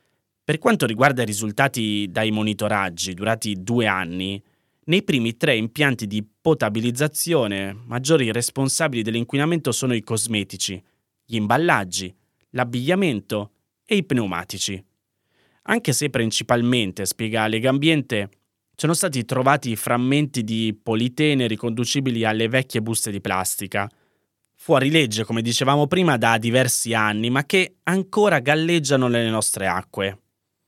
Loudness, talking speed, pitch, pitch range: -21 LUFS, 120 wpm, 115 Hz, 105-135 Hz